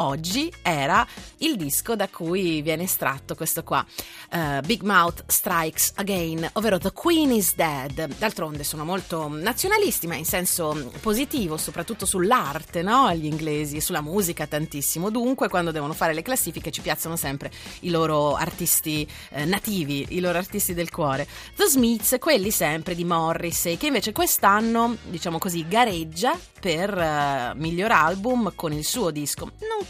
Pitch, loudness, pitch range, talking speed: 170 Hz, -23 LUFS, 155-215 Hz, 155 wpm